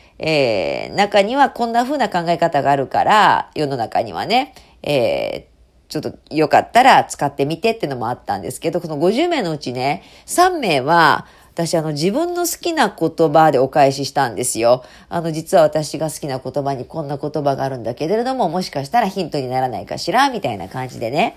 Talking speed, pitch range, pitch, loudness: 375 characters per minute, 140-200 Hz, 160 Hz, -18 LUFS